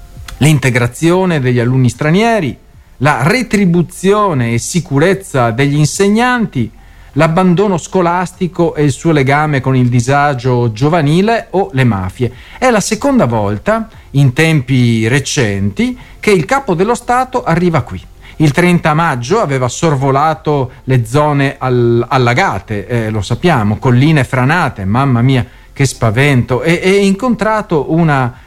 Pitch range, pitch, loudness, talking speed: 125-180 Hz, 145 Hz, -12 LUFS, 125 wpm